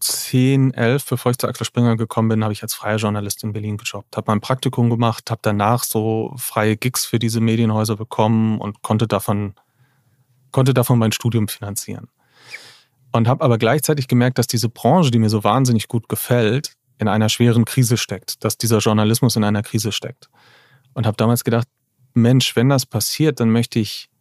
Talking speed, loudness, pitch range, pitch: 185 wpm, -18 LUFS, 110-125 Hz, 115 Hz